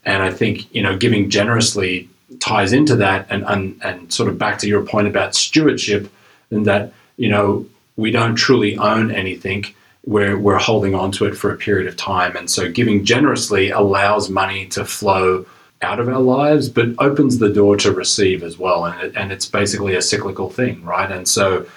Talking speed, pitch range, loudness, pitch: 200 wpm, 95-115 Hz, -16 LUFS, 100 Hz